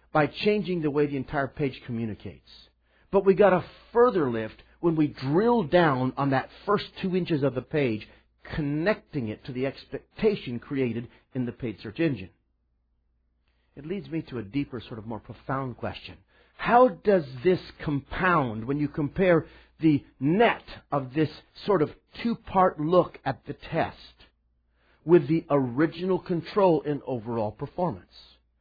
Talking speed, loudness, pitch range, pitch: 155 wpm, -26 LUFS, 110-175 Hz, 140 Hz